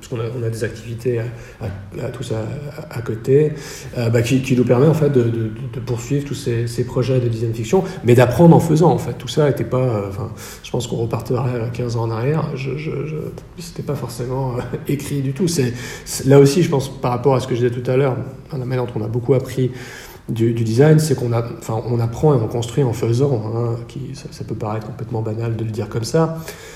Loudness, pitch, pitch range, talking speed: -19 LUFS, 125 Hz, 115-140 Hz, 240 wpm